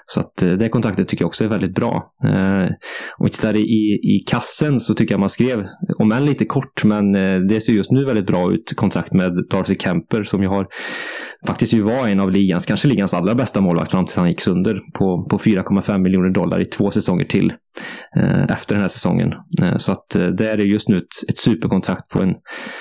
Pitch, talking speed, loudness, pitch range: 105 Hz, 210 wpm, -17 LUFS, 95-110 Hz